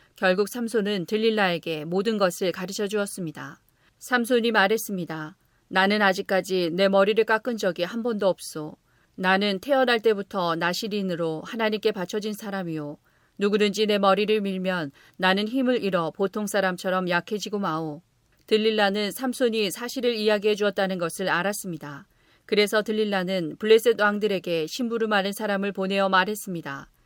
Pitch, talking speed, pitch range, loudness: 200 Hz, 345 characters per minute, 185-215 Hz, -24 LUFS